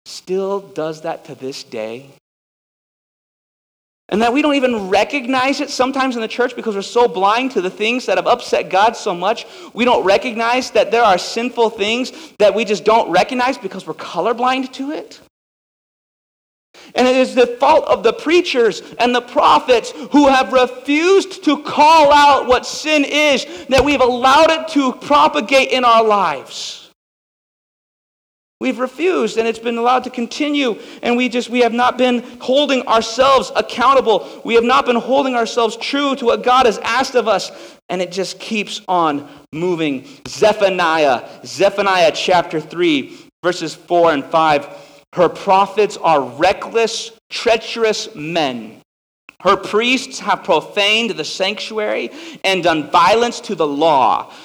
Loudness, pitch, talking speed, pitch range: -15 LUFS, 235 Hz, 155 wpm, 200-260 Hz